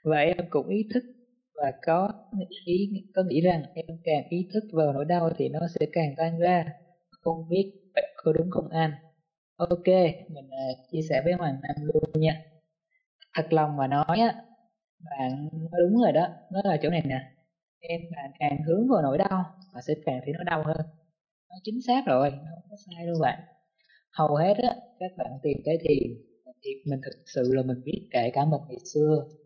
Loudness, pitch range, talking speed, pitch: -27 LUFS, 150-190 Hz, 200 wpm, 165 Hz